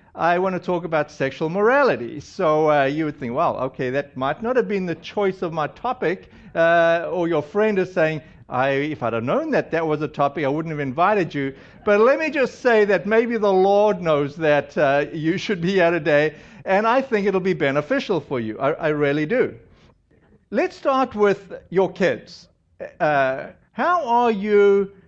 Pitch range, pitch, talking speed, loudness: 150-205 Hz, 170 Hz, 200 wpm, -20 LUFS